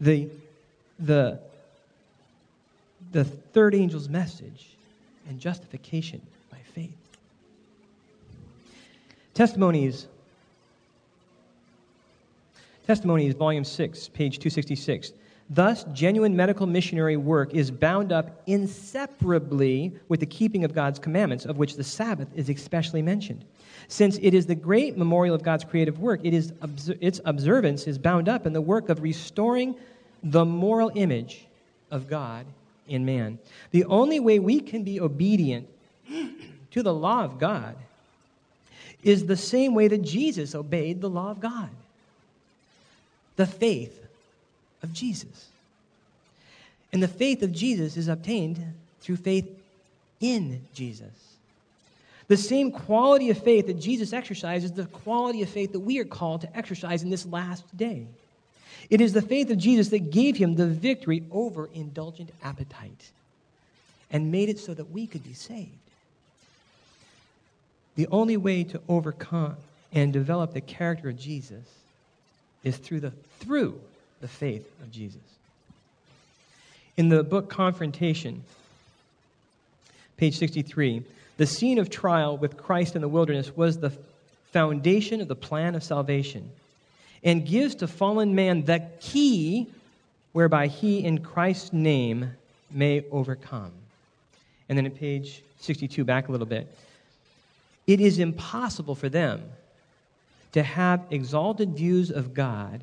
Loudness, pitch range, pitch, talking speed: -25 LUFS, 145-195 Hz, 165 Hz, 130 wpm